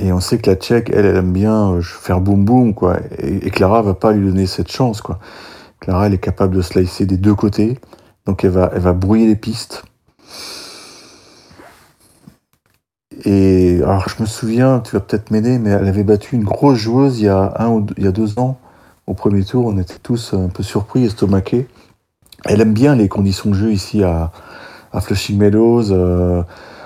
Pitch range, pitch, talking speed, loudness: 95-115 Hz, 100 Hz, 205 wpm, -15 LUFS